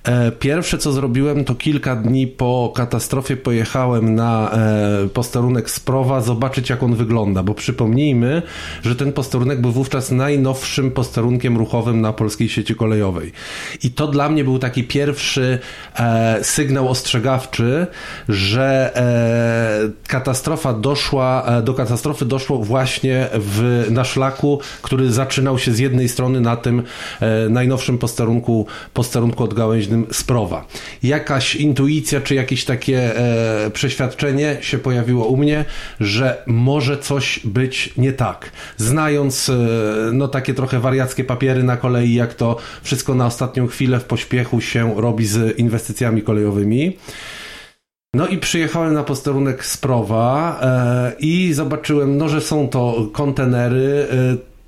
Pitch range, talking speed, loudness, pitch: 115-135 Hz, 130 wpm, -18 LUFS, 130 Hz